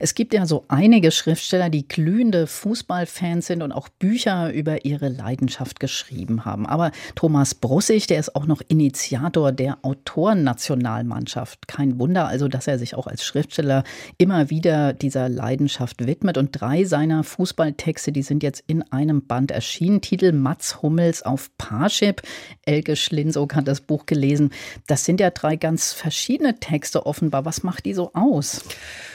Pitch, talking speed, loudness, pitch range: 150 Hz, 160 wpm, -21 LUFS, 135-170 Hz